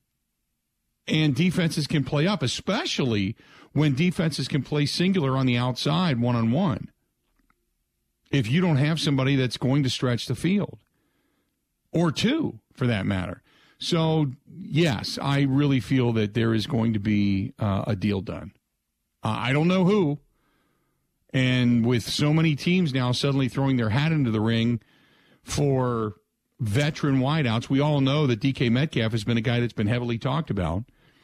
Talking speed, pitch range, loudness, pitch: 160 wpm, 115-150 Hz, -24 LUFS, 135 Hz